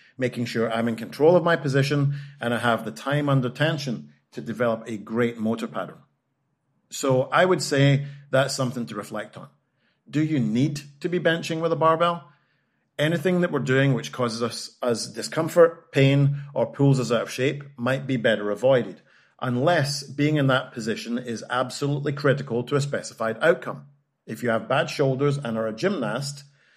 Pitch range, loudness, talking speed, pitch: 120-145 Hz, -24 LUFS, 180 wpm, 135 Hz